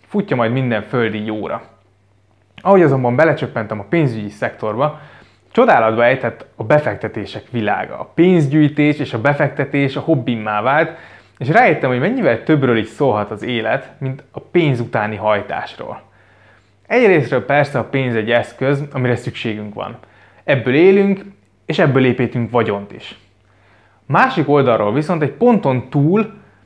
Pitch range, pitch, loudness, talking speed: 110-150 Hz, 125 Hz, -16 LUFS, 135 wpm